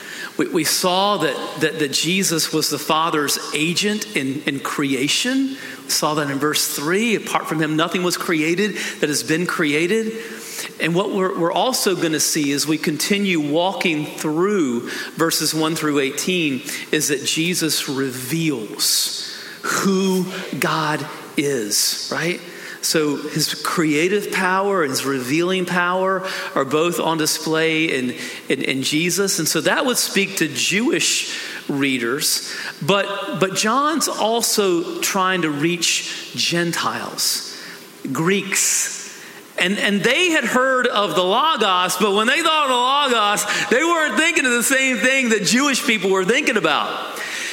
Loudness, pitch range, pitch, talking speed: -19 LUFS, 155-215 Hz, 180 Hz, 145 wpm